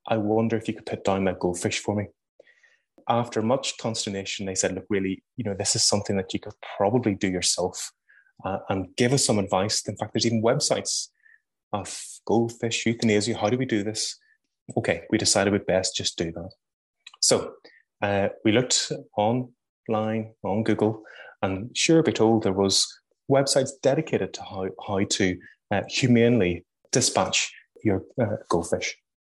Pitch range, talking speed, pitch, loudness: 100-120 Hz, 165 wpm, 110 Hz, -25 LUFS